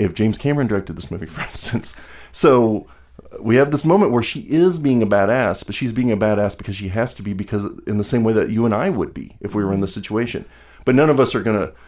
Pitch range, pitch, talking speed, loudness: 100-125 Hz, 110 Hz, 270 wpm, -19 LUFS